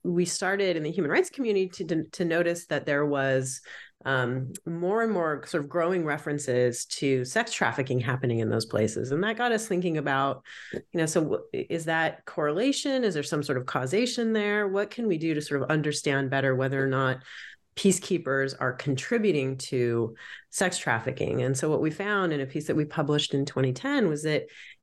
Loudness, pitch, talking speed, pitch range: -27 LUFS, 155 Hz, 195 wpm, 135-190 Hz